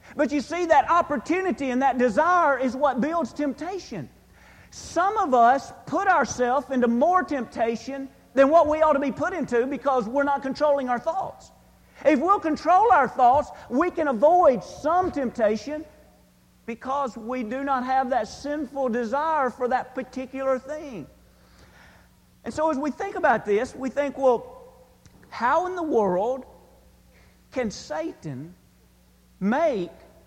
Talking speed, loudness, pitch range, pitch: 145 wpm, -23 LUFS, 250-310 Hz, 275 Hz